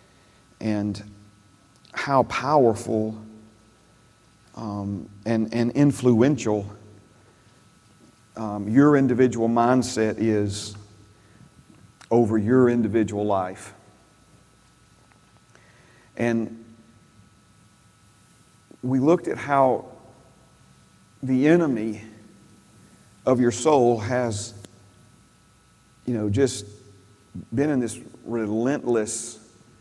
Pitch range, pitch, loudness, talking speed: 105-120 Hz, 110 Hz, -23 LUFS, 70 wpm